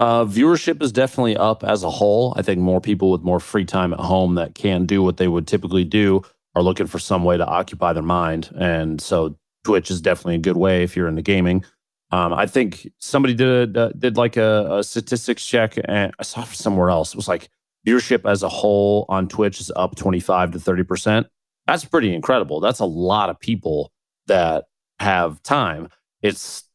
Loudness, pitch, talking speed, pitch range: -19 LUFS, 95 Hz, 205 wpm, 90-110 Hz